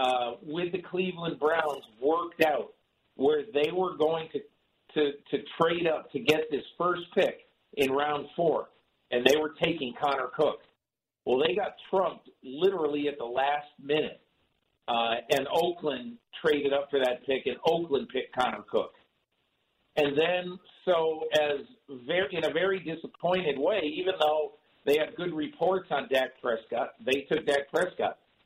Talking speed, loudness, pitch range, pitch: 160 wpm, -29 LUFS, 145-175 Hz, 155 Hz